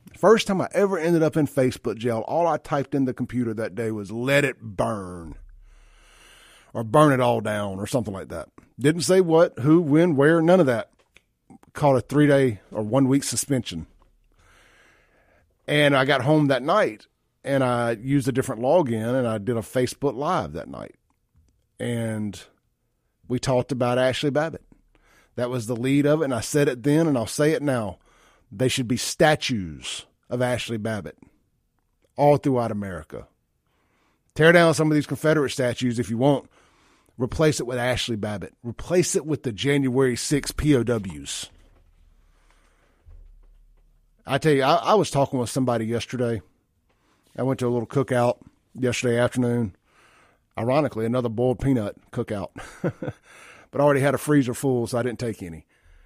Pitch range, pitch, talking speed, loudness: 110-145 Hz, 125 Hz, 165 wpm, -23 LUFS